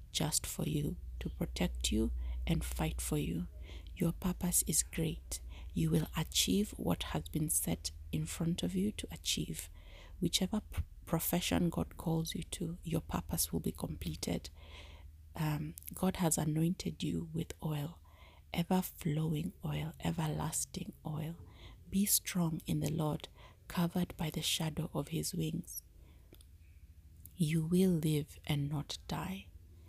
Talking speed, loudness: 140 wpm, -36 LUFS